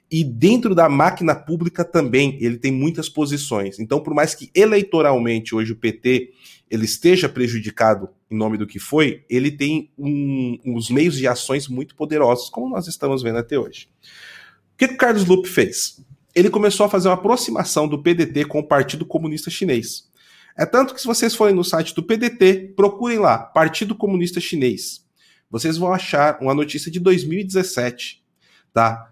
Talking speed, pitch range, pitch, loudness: 170 wpm, 130-185 Hz, 155 Hz, -19 LUFS